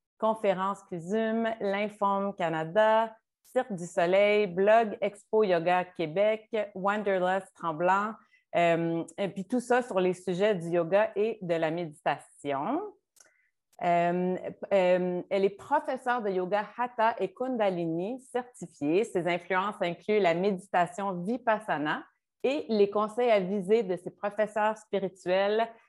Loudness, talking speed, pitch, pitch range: -29 LUFS, 125 wpm, 200 Hz, 180-220 Hz